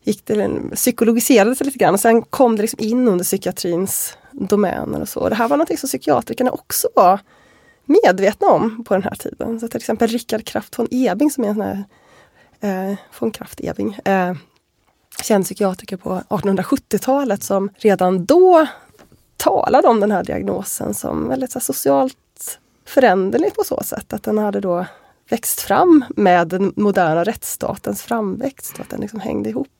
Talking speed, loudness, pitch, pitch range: 145 wpm, -17 LUFS, 215 Hz, 190-250 Hz